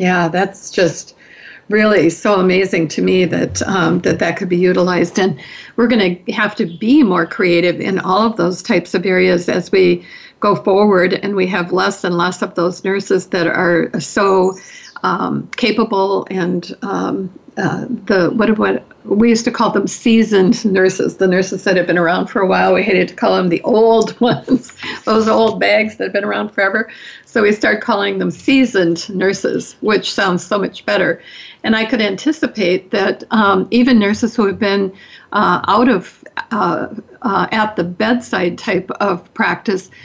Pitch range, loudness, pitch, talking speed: 180-220 Hz, -15 LUFS, 195 Hz, 180 wpm